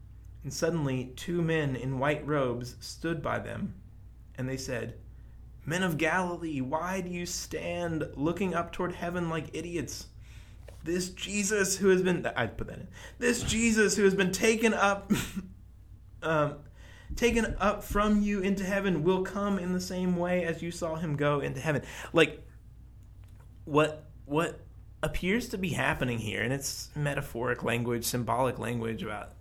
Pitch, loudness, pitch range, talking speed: 155 Hz, -30 LUFS, 120-185 Hz, 155 wpm